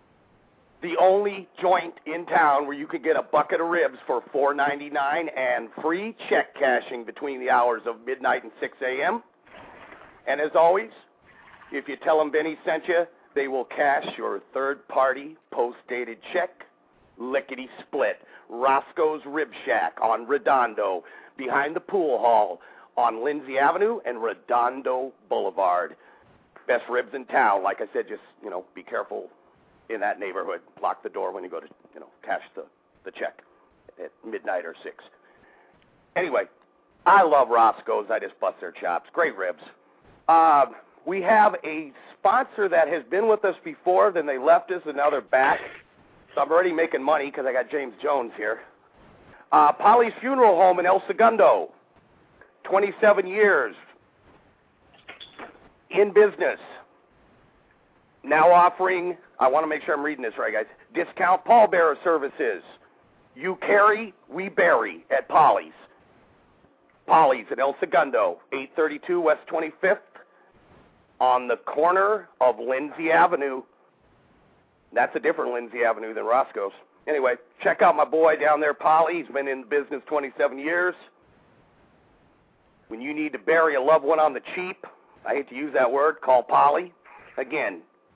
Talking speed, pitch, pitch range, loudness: 150 wpm, 170 Hz, 145-210 Hz, -23 LUFS